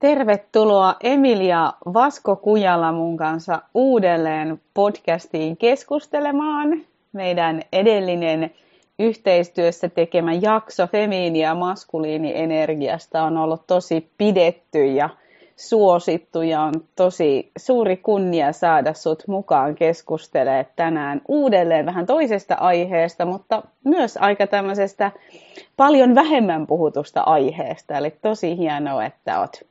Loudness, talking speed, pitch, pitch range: -19 LUFS, 105 wpm, 180 Hz, 160-210 Hz